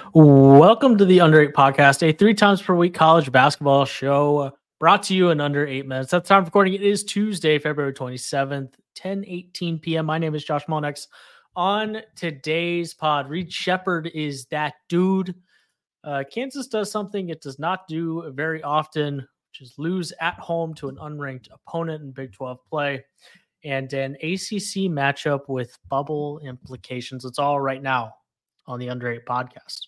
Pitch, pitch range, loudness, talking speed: 155 Hz, 140-180 Hz, -20 LUFS, 175 wpm